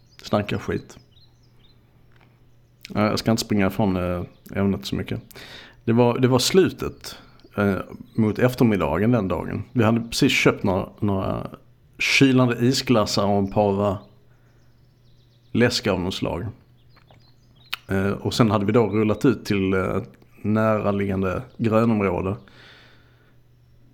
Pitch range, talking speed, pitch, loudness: 100-125 Hz, 120 wpm, 115 Hz, -22 LUFS